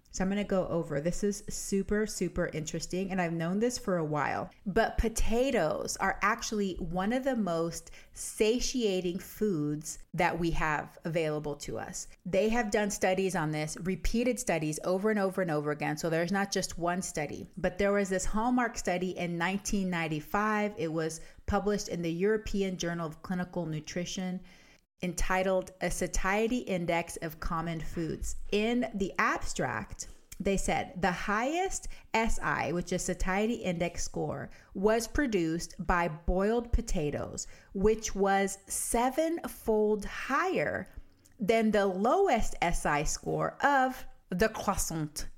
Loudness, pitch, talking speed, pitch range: -31 LUFS, 185 Hz, 145 wpm, 170-210 Hz